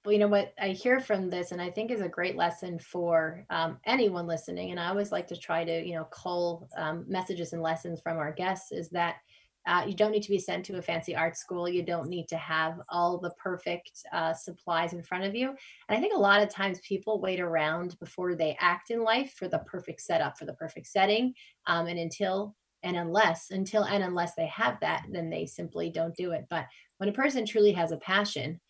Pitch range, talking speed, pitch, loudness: 165-200 Hz, 235 wpm, 175 Hz, -30 LUFS